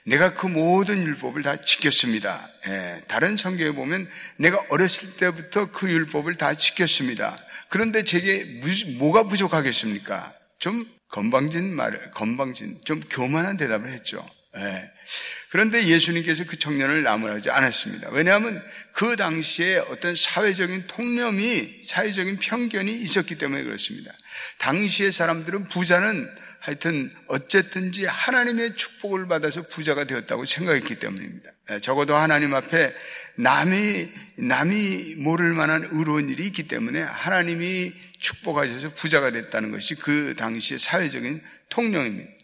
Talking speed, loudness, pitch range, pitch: 325 characters per minute, -23 LUFS, 155-200 Hz, 175 Hz